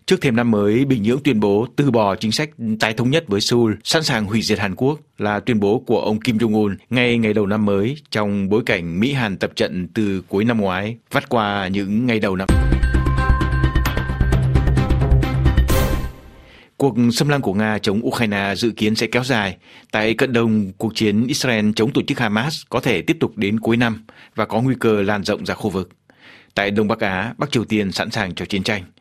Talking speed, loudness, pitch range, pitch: 210 wpm, -19 LUFS, 95-120 Hz, 110 Hz